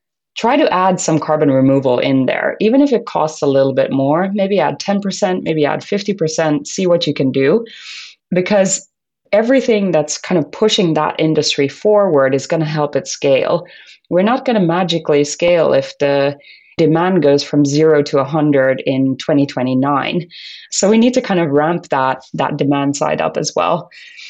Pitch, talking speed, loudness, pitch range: 155 Hz, 180 wpm, -15 LUFS, 140-195 Hz